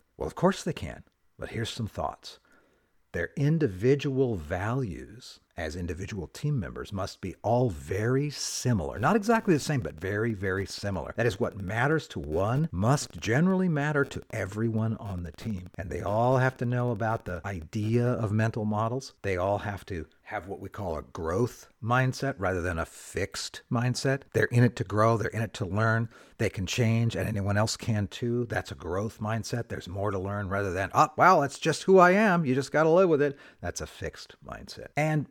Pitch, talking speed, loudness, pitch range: 115 Hz, 200 wpm, -28 LUFS, 100-130 Hz